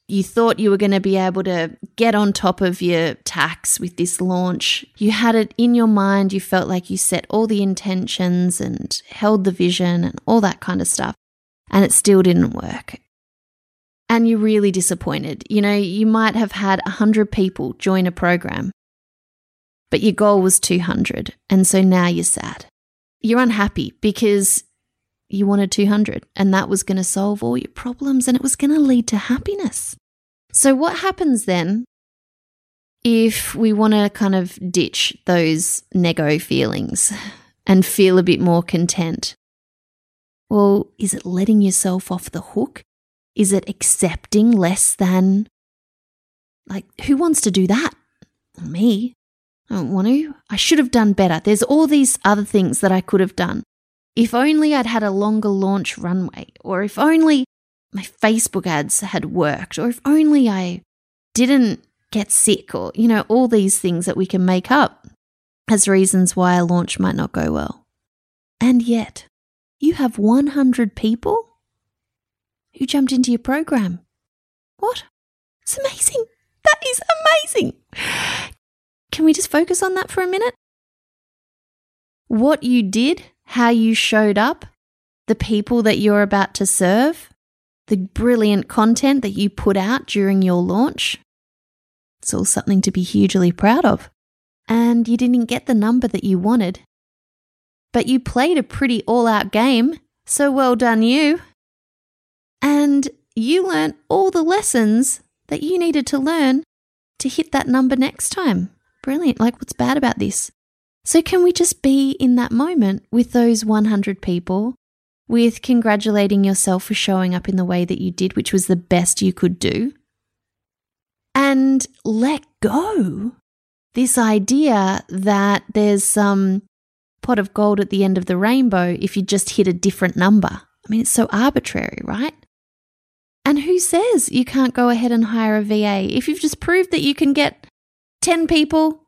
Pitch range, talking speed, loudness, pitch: 195-260 Hz, 165 wpm, -17 LUFS, 215 Hz